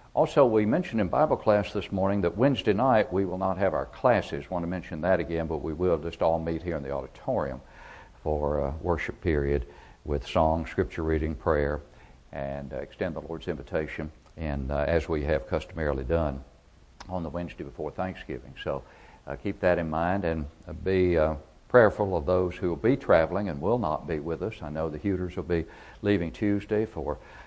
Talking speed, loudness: 195 wpm, -28 LUFS